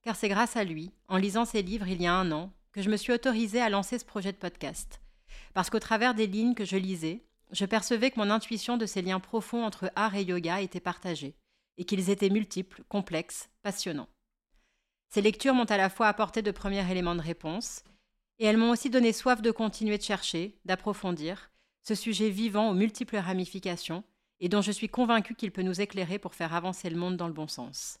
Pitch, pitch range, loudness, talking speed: 205 Hz, 185-225 Hz, -30 LUFS, 215 wpm